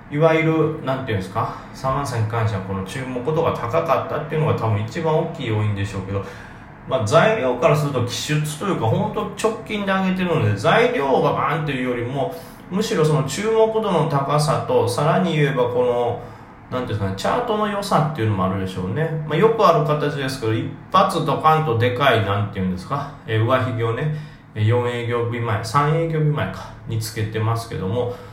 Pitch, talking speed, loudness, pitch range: 135 Hz, 415 characters per minute, -20 LUFS, 115-160 Hz